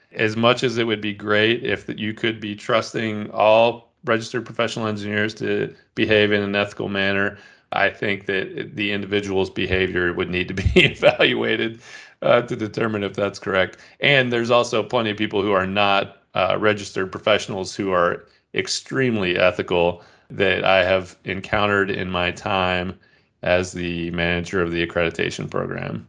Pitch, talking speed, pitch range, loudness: 105 Hz, 160 wpm, 95-110 Hz, -21 LUFS